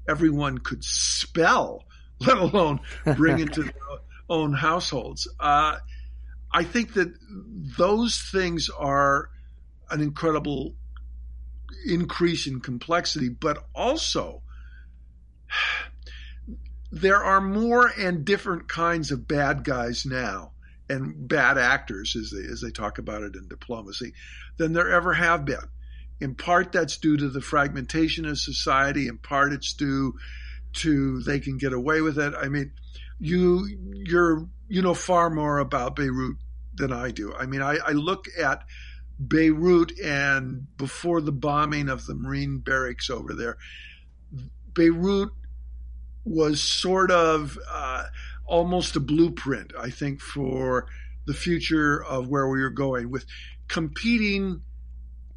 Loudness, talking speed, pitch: -24 LUFS, 130 wpm, 140 Hz